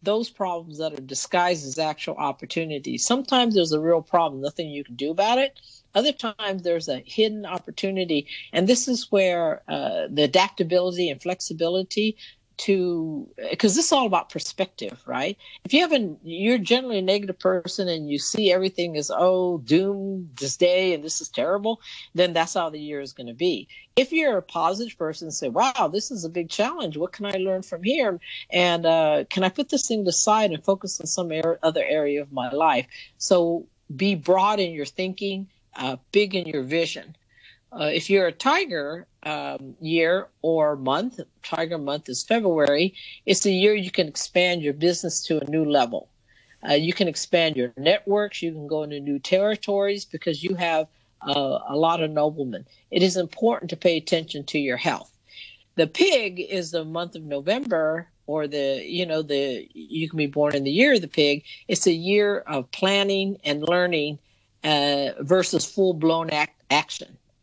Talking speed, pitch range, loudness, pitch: 185 wpm, 155-195 Hz, -23 LUFS, 175 Hz